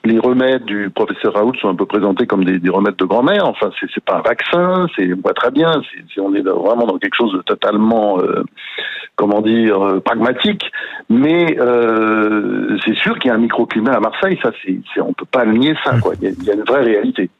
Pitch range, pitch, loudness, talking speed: 100-125 Hz, 110 Hz, -15 LUFS, 245 wpm